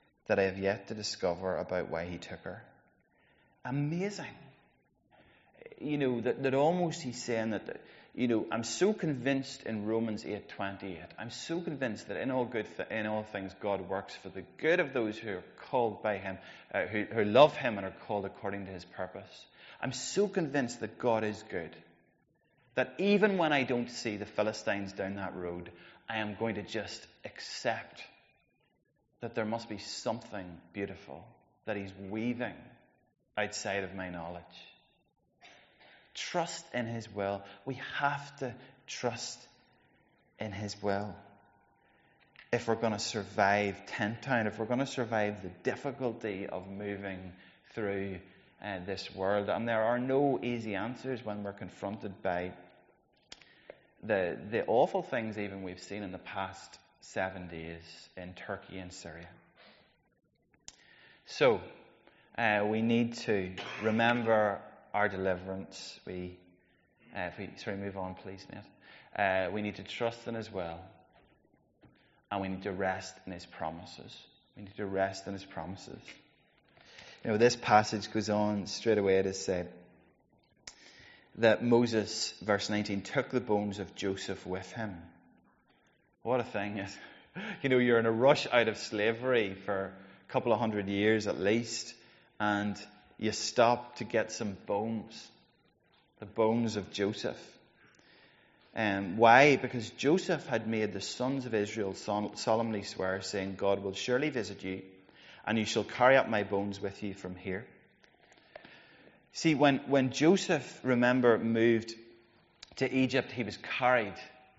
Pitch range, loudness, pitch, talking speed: 95-120 Hz, -32 LUFS, 105 Hz, 150 wpm